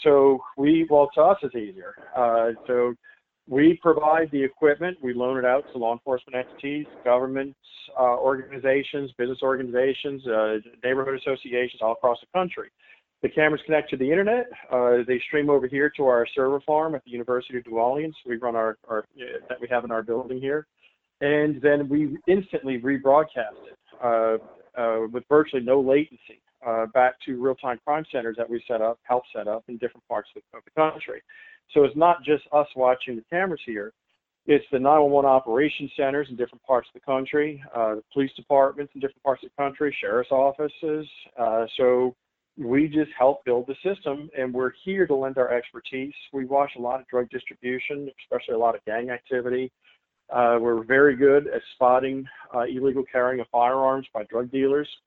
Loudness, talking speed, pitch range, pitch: -24 LUFS, 190 wpm, 125-145 Hz, 135 Hz